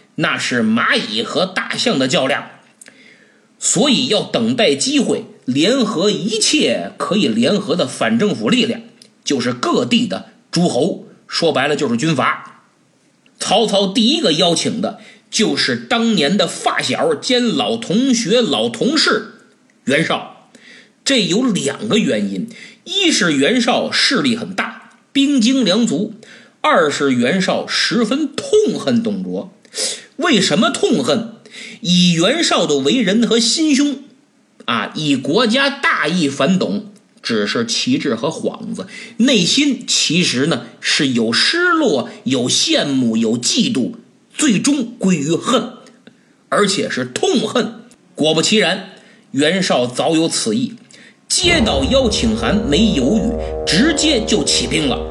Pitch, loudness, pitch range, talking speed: 230 Hz, -15 LUFS, 215-255 Hz, 190 characters per minute